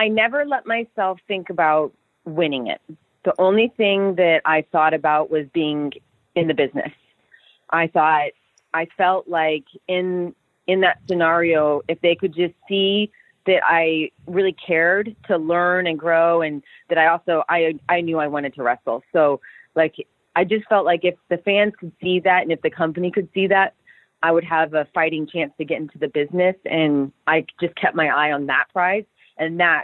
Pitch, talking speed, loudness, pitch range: 170 Hz, 190 wpm, -20 LUFS, 155-185 Hz